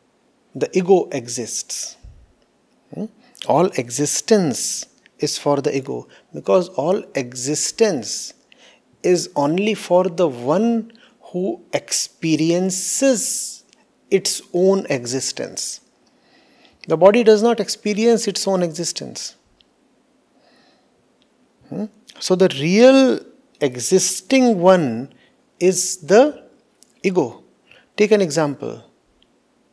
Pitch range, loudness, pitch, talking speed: 155-220 Hz, -18 LUFS, 185 Hz, 85 wpm